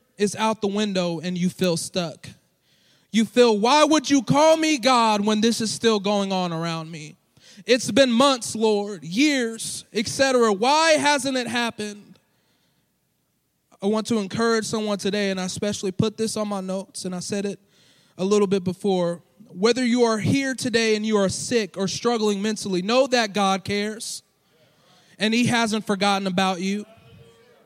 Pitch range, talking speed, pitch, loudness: 190-230 Hz, 170 wpm, 210 Hz, -22 LUFS